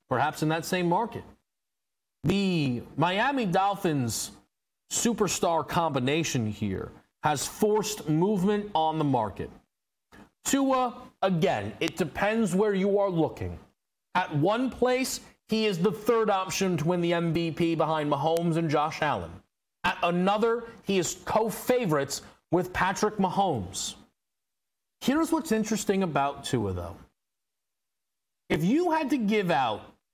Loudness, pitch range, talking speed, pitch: -27 LUFS, 155-215 Hz, 125 wpm, 185 Hz